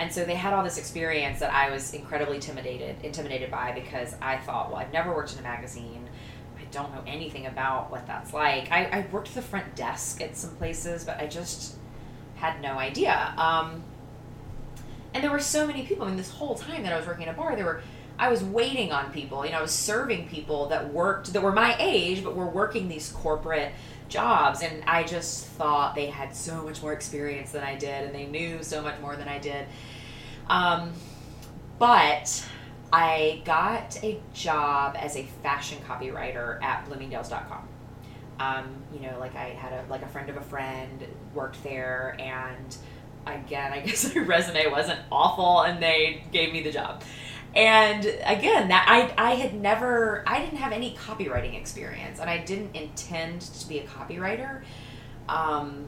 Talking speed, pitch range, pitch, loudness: 190 wpm, 130-165 Hz, 145 Hz, -27 LUFS